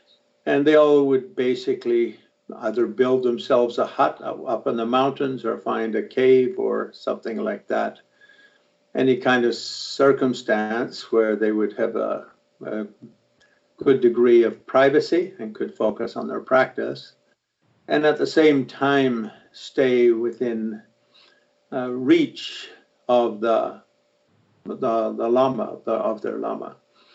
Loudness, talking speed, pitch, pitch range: -22 LUFS, 135 wpm, 130 Hz, 115-150 Hz